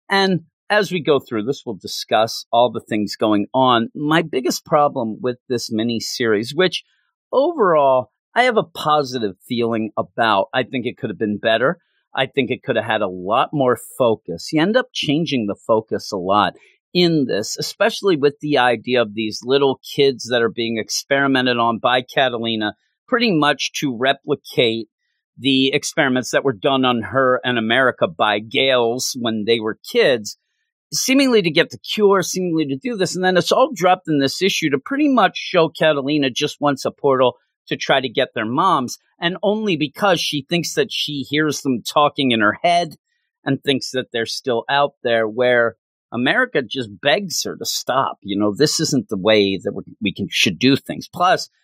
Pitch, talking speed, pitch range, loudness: 135 Hz, 185 wpm, 115-165 Hz, -18 LUFS